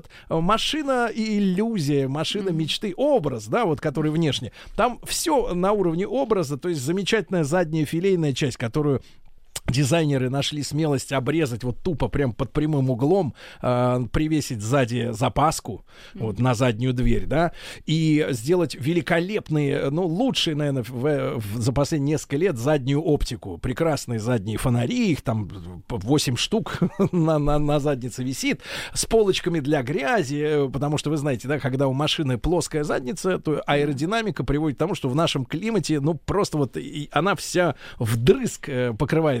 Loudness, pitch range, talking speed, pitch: -23 LUFS, 135-170 Hz, 150 wpm, 150 Hz